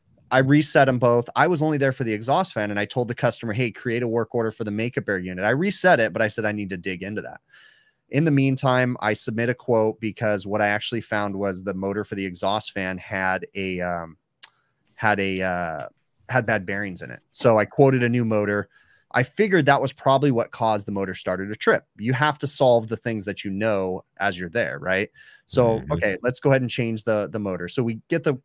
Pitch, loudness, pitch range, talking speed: 115 Hz, -23 LUFS, 100-130 Hz, 240 wpm